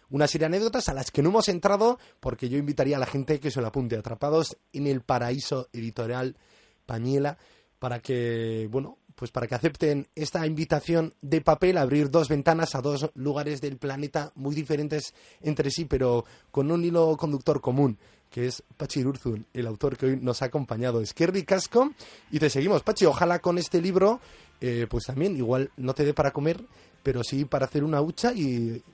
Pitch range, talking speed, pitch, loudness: 130-160 Hz, 195 wpm, 145 Hz, -27 LUFS